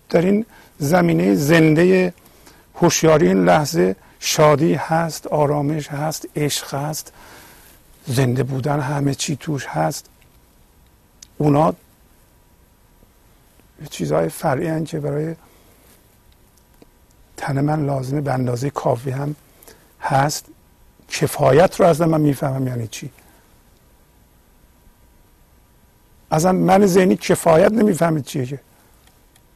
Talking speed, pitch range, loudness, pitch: 95 wpm, 95-160 Hz, -18 LUFS, 140 Hz